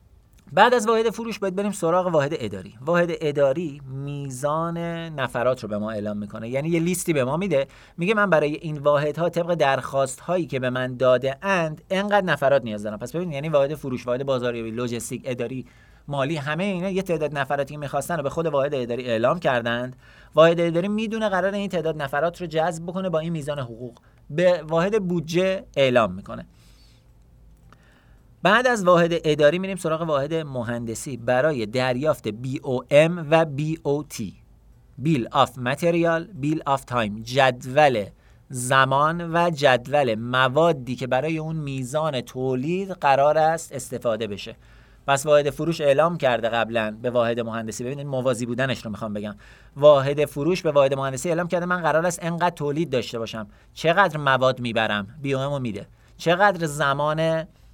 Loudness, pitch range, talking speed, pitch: -23 LUFS, 125-170 Hz, 165 wpm, 145 Hz